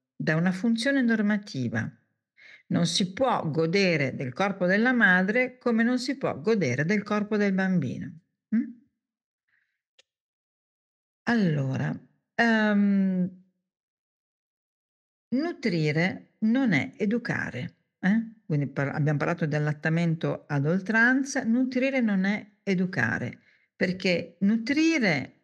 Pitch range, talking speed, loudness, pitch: 160-230 Hz, 100 wpm, -26 LUFS, 195 Hz